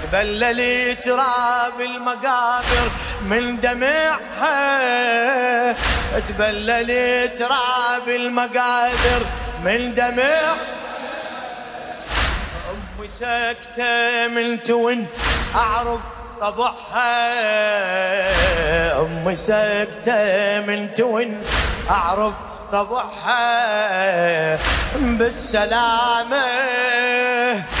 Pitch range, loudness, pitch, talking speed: 215-245 Hz, -19 LUFS, 240 Hz, 50 wpm